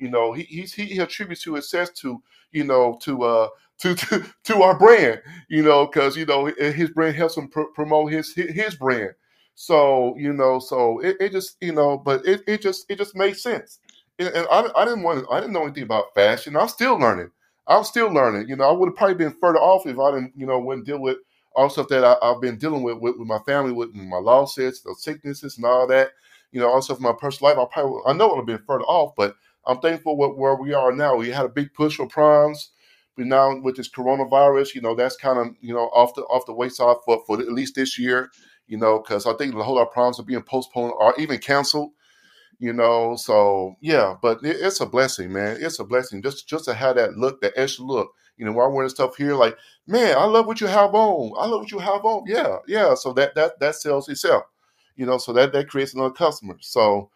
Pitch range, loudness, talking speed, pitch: 125-160 Hz, -20 LUFS, 250 wpm, 140 Hz